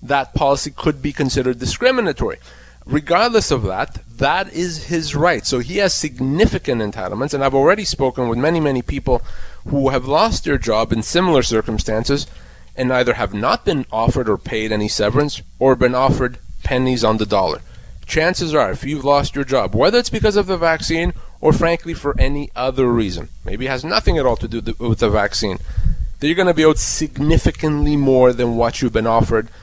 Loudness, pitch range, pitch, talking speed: -18 LUFS, 115-155 Hz, 135 Hz, 190 wpm